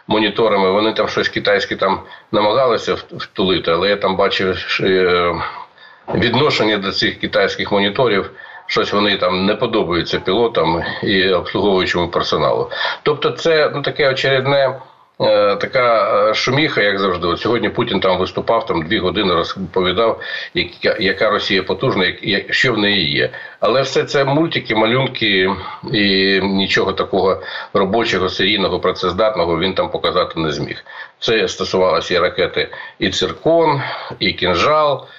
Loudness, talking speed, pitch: -16 LUFS, 135 wpm, 130 Hz